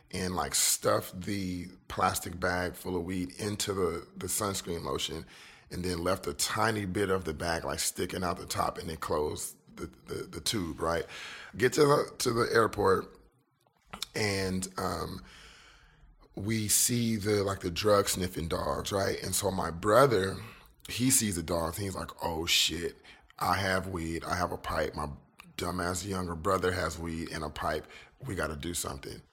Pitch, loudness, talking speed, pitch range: 95 Hz, -31 LUFS, 175 wpm, 85-100 Hz